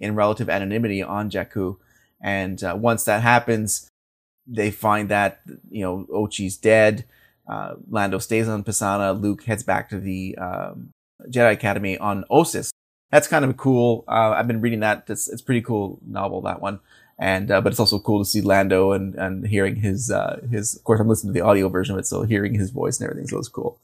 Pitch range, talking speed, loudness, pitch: 95-110 Hz, 210 wpm, -21 LUFS, 105 Hz